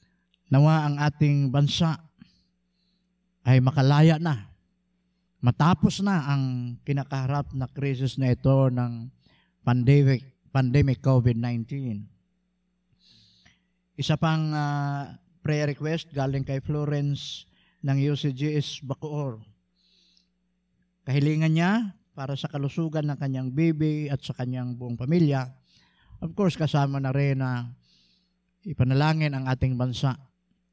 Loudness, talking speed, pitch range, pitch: -25 LUFS, 105 wpm, 130-160 Hz, 145 Hz